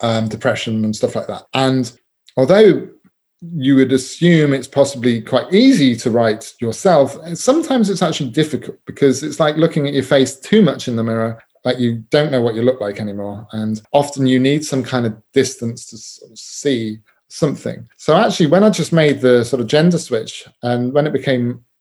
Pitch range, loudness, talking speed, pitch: 120-155 Hz, -16 LUFS, 195 wpm, 130 Hz